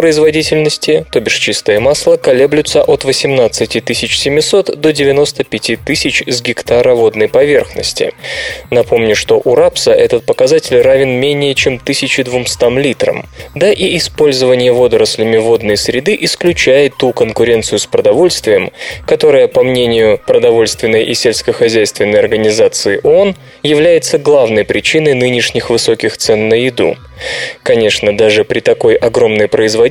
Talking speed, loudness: 120 wpm, -10 LUFS